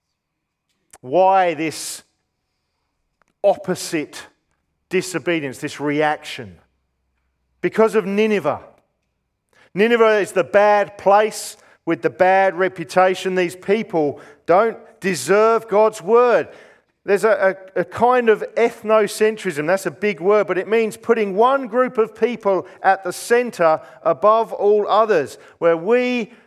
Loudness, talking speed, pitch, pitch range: -18 LUFS, 115 wpm, 190 Hz, 165-215 Hz